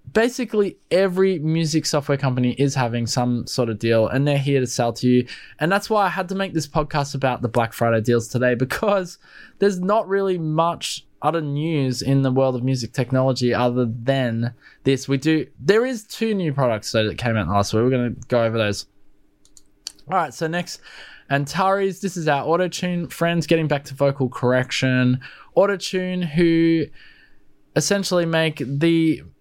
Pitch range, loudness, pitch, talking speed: 125-175 Hz, -21 LUFS, 140 Hz, 180 wpm